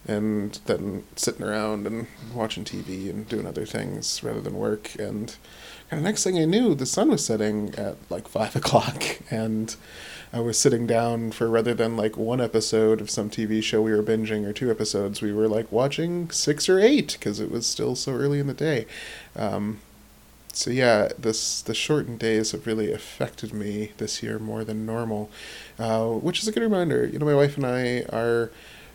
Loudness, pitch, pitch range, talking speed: -25 LUFS, 115 Hz, 110-125 Hz, 195 wpm